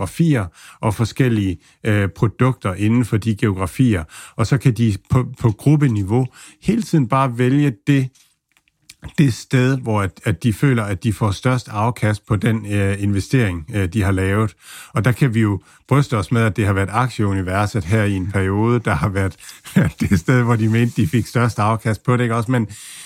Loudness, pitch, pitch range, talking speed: -18 LUFS, 115 Hz, 105-125 Hz, 200 wpm